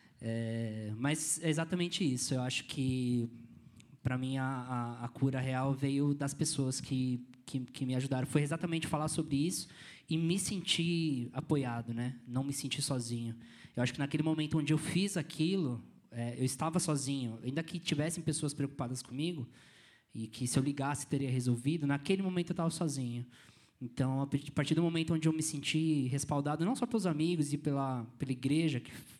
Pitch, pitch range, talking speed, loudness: 140 Hz, 125-160 Hz, 180 wpm, -35 LUFS